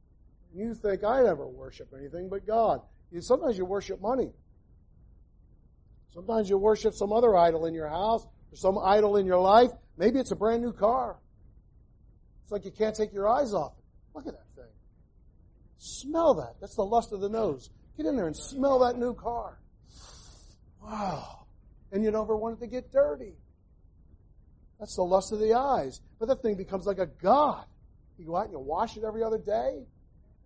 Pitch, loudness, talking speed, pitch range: 200 Hz, -28 LUFS, 185 wpm, 135-225 Hz